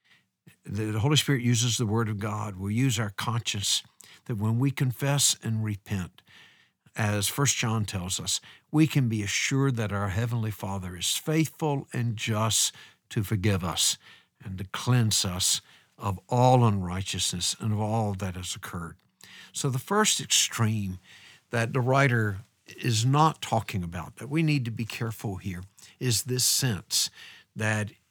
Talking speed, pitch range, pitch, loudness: 155 wpm, 100-125 Hz, 110 Hz, -27 LUFS